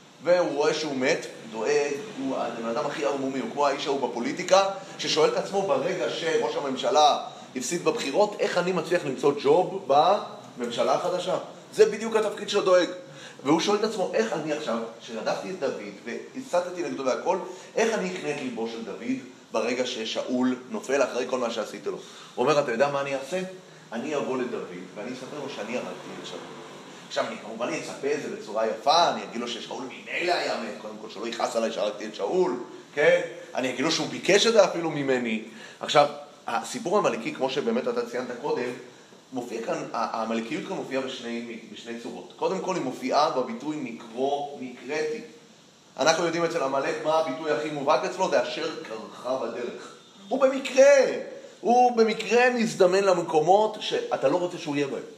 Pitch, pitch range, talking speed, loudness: 170 Hz, 135-215 Hz, 175 wpm, -26 LUFS